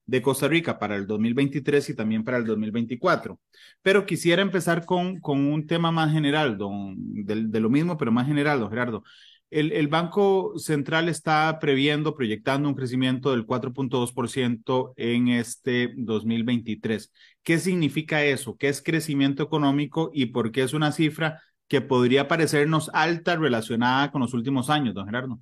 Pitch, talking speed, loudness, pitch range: 140 Hz, 170 wpm, -24 LUFS, 120-155 Hz